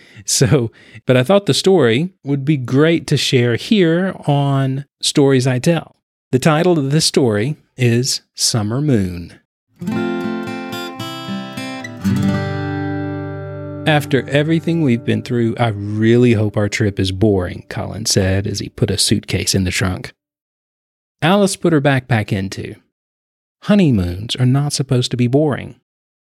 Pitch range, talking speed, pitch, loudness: 100-145 Hz, 135 wpm, 125 Hz, -16 LUFS